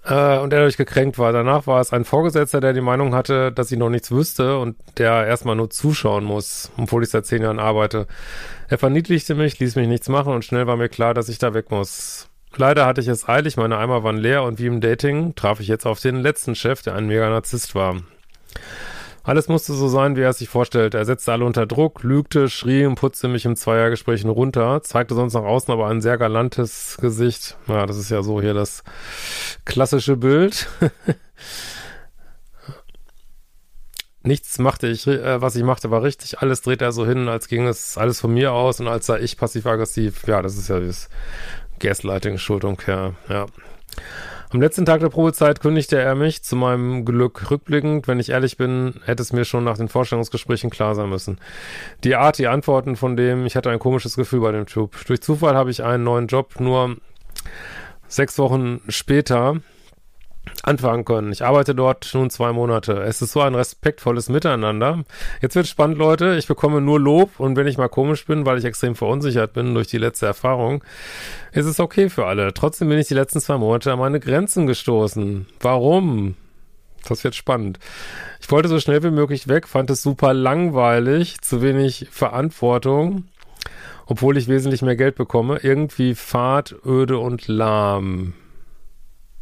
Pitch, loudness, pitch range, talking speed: 125 Hz, -19 LUFS, 115-140 Hz, 185 wpm